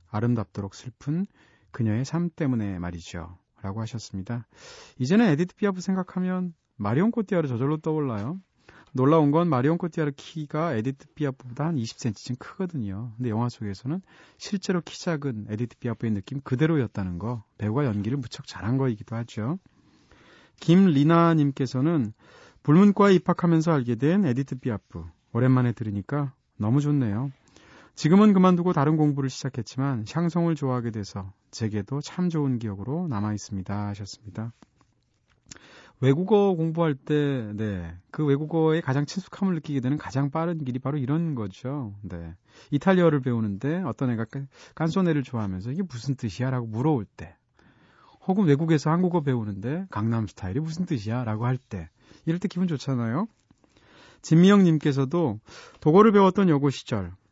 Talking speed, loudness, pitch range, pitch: 355 characters per minute, -25 LUFS, 115-160 Hz, 135 Hz